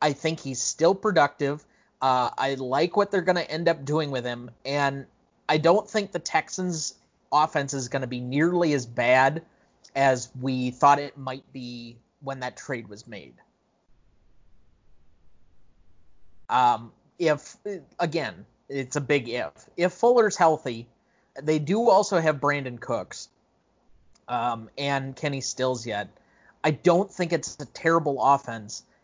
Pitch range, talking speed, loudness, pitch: 125-160 Hz, 145 wpm, -25 LUFS, 135 Hz